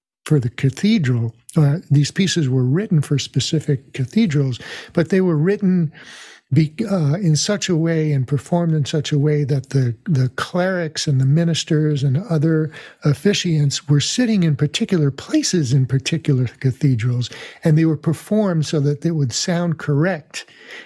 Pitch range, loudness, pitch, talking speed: 140-175 Hz, -19 LUFS, 155 Hz, 160 wpm